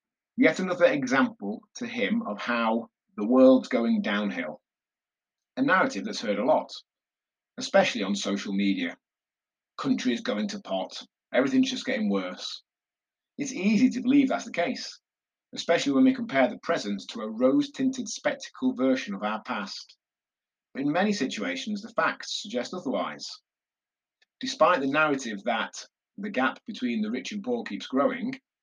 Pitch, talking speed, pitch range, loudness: 240 Hz, 145 wpm, 185-260 Hz, -27 LUFS